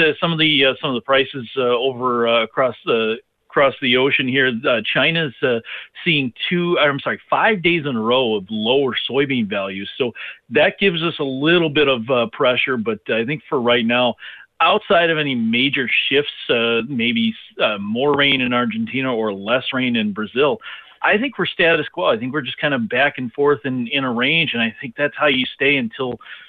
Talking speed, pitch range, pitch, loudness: 210 wpm, 120-155 Hz, 135 Hz, -18 LUFS